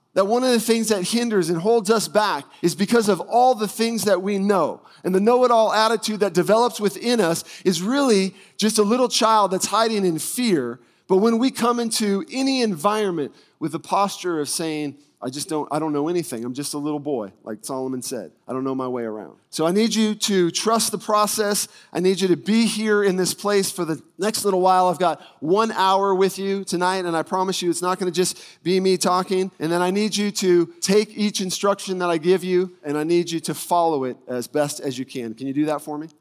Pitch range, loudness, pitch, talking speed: 165-210 Hz, -21 LUFS, 185 Hz, 240 wpm